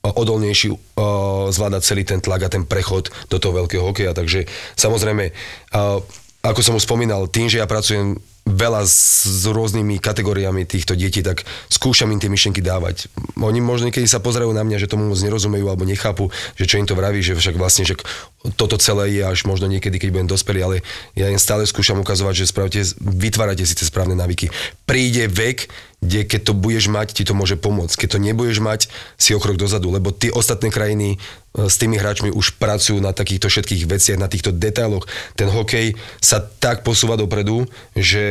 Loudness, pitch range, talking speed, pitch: -17 LUFS, 95-110 Hz, 190 wpm, 100 Hz